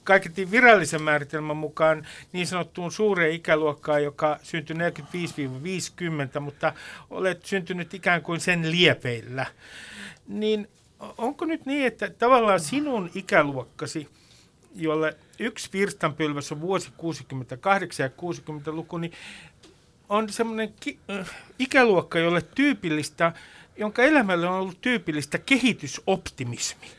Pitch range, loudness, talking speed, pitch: 155-200 Hz, -25 LUFS, 105 wpm, 170 Hz